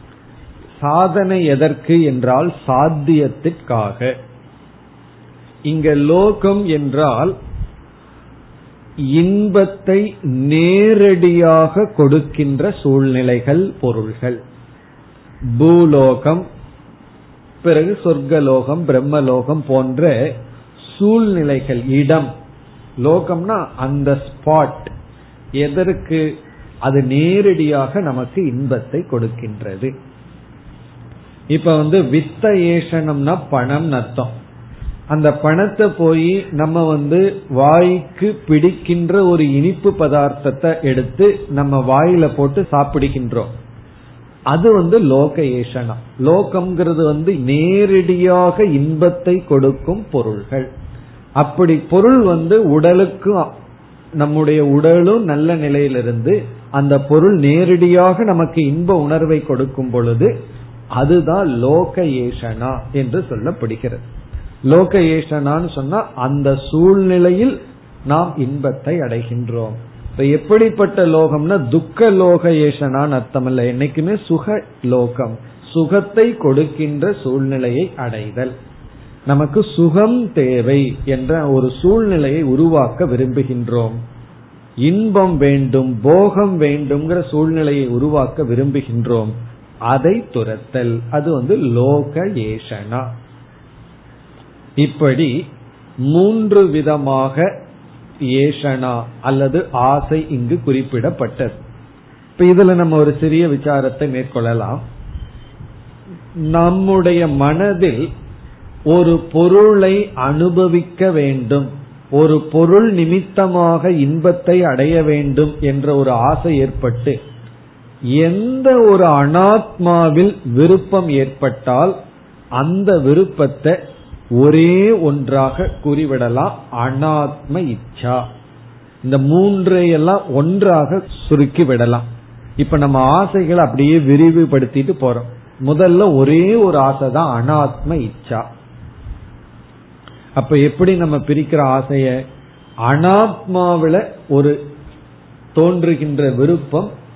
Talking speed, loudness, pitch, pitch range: 75 wpm, -14 LUFS, 145 Hz, 130-175 Hz